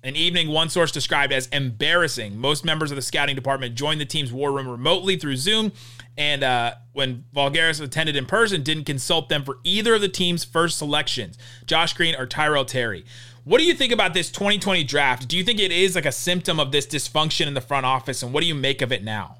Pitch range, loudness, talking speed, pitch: 130-170 Hz, -21 LUFS, 230 wpm, 145 Hz